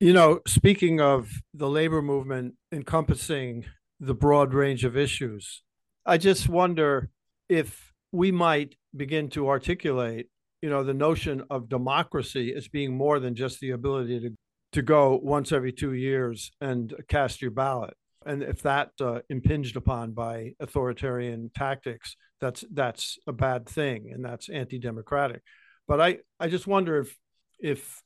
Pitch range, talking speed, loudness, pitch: 125-150 Hz, 150 wpm, -26 LUFS, 135 Hz